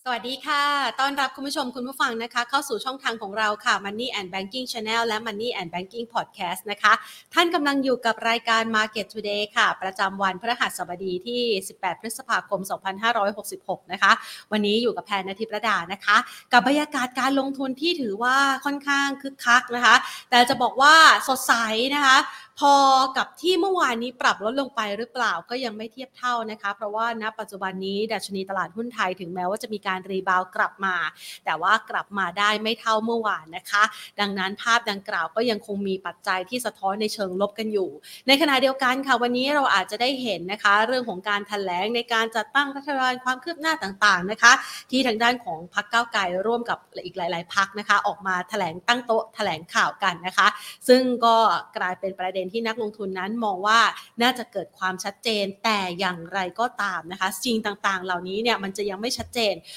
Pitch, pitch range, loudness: 220 Hz, 195-250 Hz, -23 LUFS